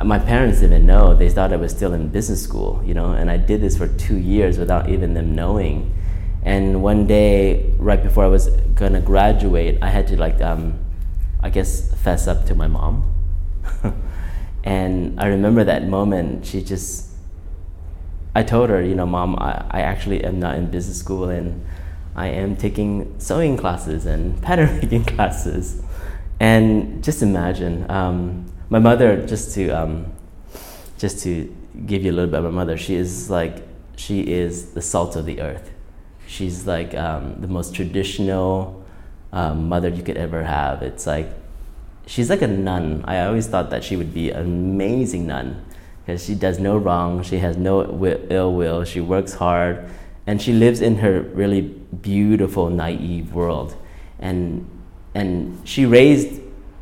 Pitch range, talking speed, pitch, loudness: 85-95 Hz, 170 wpm, 90 Hz, -20 LUFS